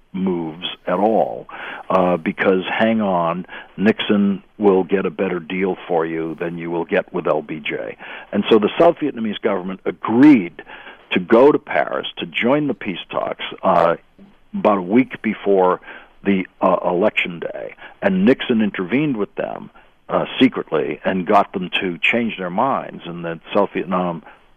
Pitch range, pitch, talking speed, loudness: 90-110 Hz, 95 Hz, 155 wpm, -19 LUFS